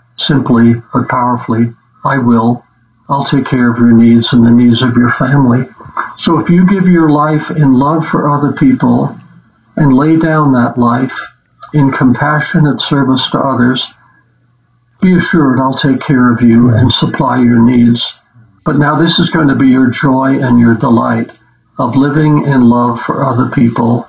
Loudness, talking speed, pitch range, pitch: -9 LUFS, 170 wpm, 120-145 Hz, 130 Hz